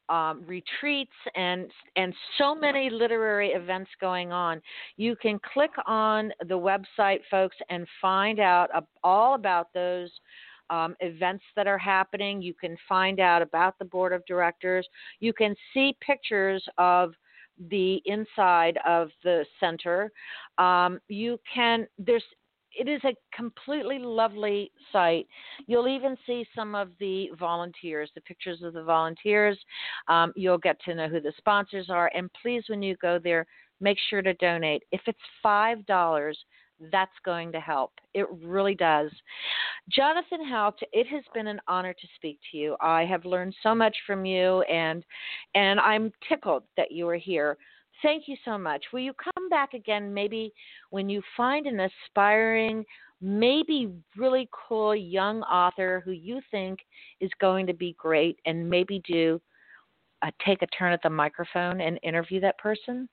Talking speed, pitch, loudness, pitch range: 160 wpm, 190 Hz, -27 LUFS, 175-220 Hz